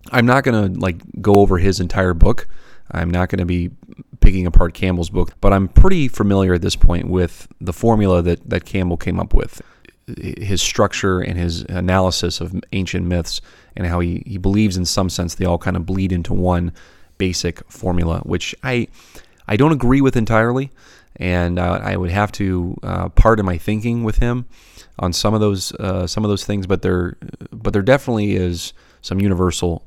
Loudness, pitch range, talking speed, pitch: -18 LUFS, 85-105 Hz, 190 wpm, 90 Hz